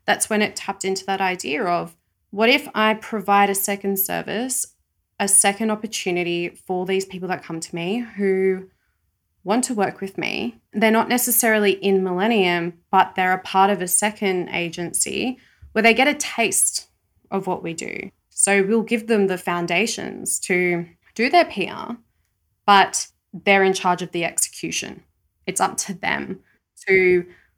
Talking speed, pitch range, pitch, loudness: 165 wpm, 180-220 Hz, 195 Hz, -20 LUFS